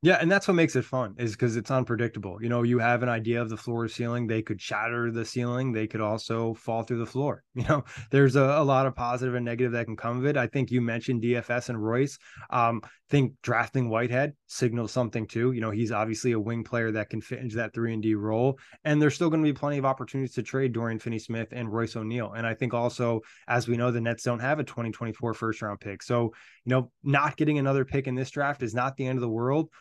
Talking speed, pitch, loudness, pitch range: 260 wpm, 120 Hz, -28 LUFS, 115-130 Hz